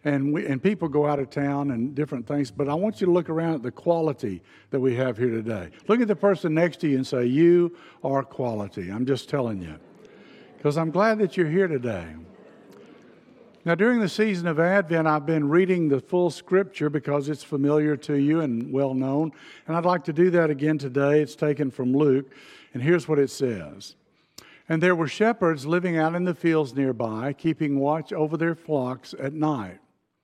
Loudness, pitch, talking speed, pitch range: -24 LUFS, 150 Hz, 205 wpm, 135-170 Hz